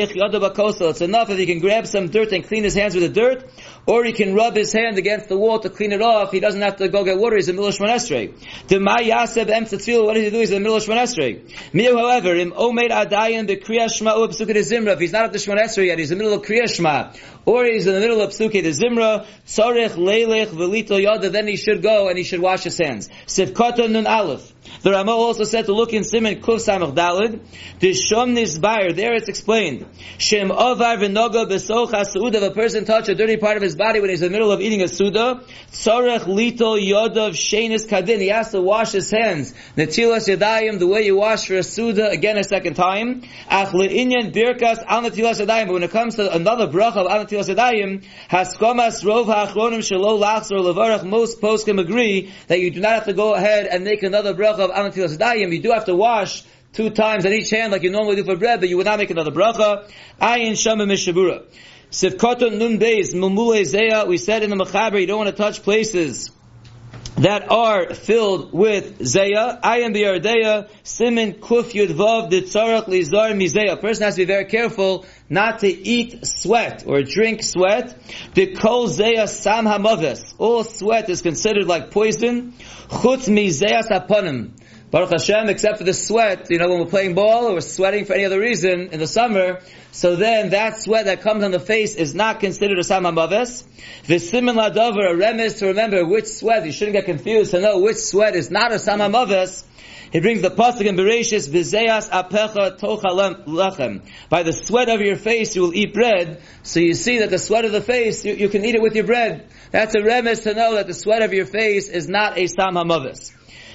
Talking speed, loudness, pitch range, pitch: 205 wpm, -18 LUFS, 190-225 Hz, 210 Hz